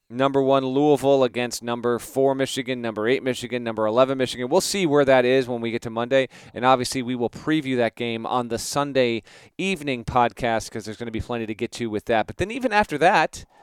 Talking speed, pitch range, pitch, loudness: 225 wpm, 115-135 Hz, 125 Hz, -22 LUFS